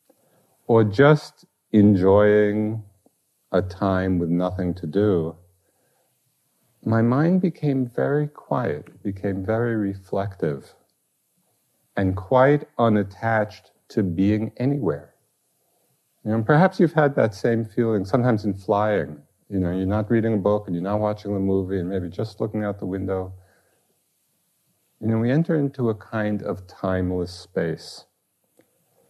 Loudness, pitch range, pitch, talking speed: -22 LUFS, 95-115 Hz, 105 Hz, 135 wpm